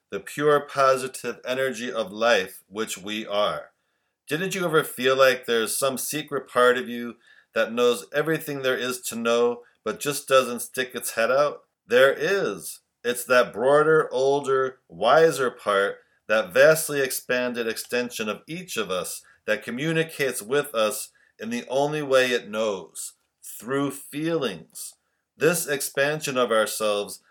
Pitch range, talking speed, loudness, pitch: 120-145 Hz, 145 wpm, -24 LUFS, 130 Hz